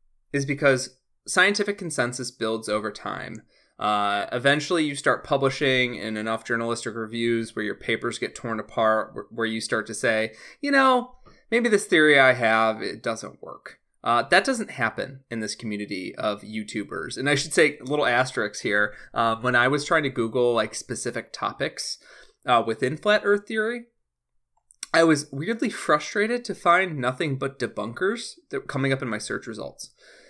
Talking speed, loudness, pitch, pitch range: 170 wpm, -24 LUFS, 130 Hz, 110-180 Hz